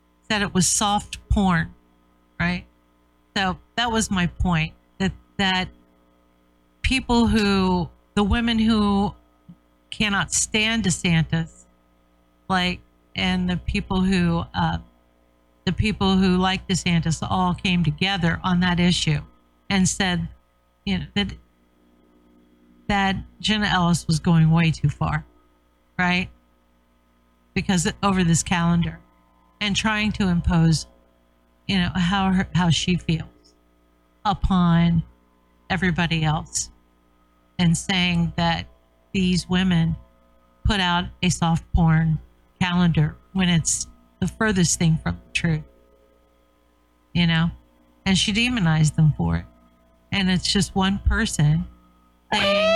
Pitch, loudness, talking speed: 160 Hz, -22 LUFS, 115 wpm